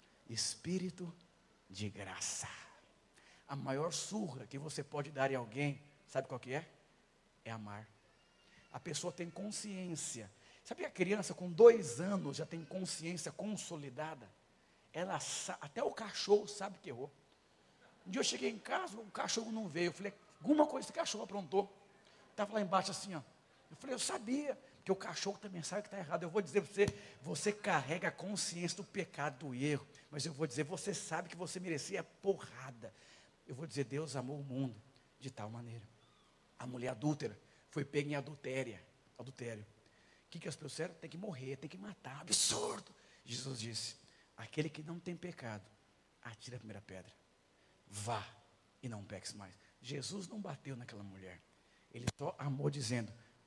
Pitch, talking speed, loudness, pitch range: 150 Hz, 170 wpm, -40 LUFS, 125-185 Hz